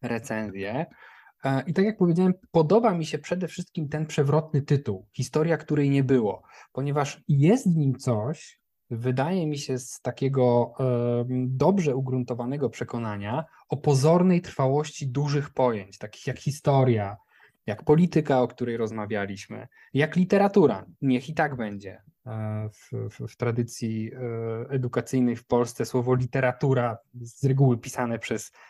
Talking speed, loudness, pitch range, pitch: 130 wpm, -26 LUFS, 120-150 Hz, 130 Hz